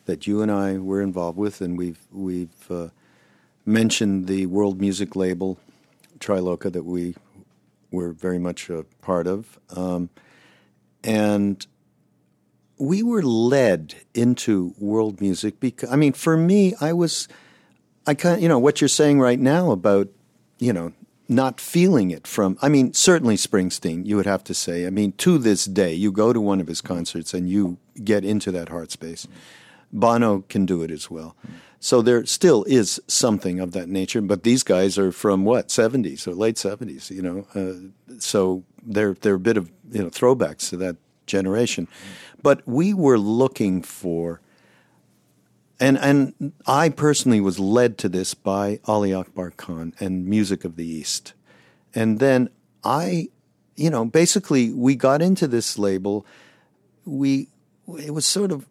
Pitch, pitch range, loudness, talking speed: 100 Hz, 90-130 Hz, -21 LUFS, 165 wpm